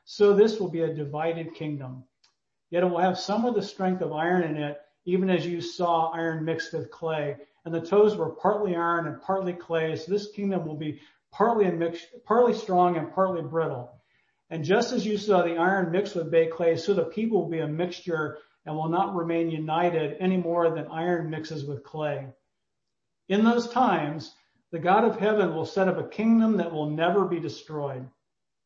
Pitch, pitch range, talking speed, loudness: 170 Hz, 160-190 Hz, 200 wpm, -26 LUFS